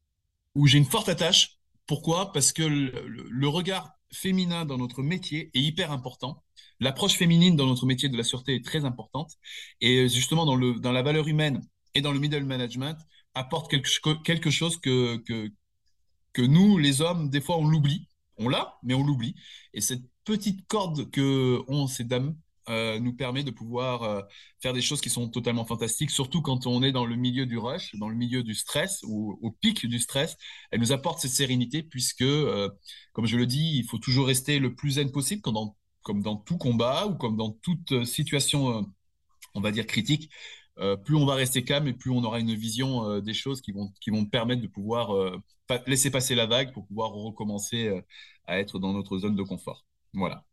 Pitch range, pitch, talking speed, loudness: 115-145 Hz, 130 Hz, 210 wpm, -27 LUFS